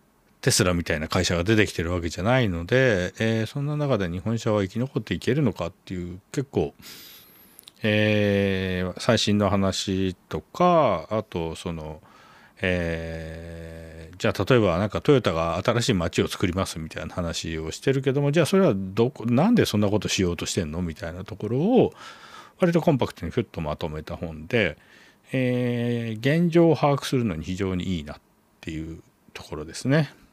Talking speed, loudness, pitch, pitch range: 340 characters per minute, -24 LUFS, 100 Hz, 85-125 Hz